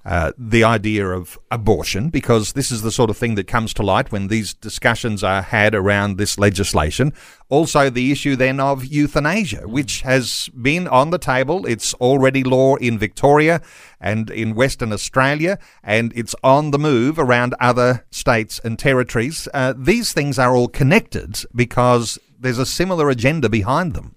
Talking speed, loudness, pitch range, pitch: 170 wpm, -17 LUFS, 110-140 Hz, 125 Hz